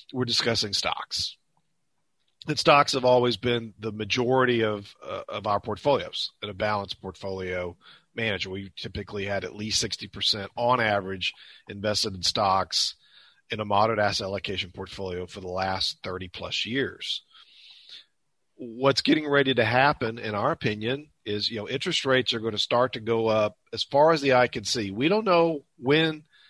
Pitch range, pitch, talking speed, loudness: 100-125 Hz, 110 Hz, 170 wpm, -25 LUFS